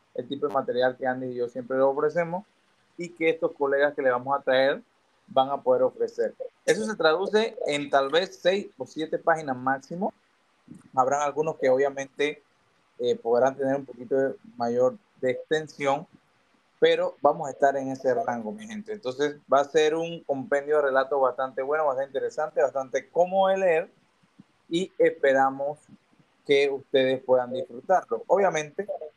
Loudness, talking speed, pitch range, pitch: -26 LUFS, 165 wpm, 135-190 Hz, 145 Hz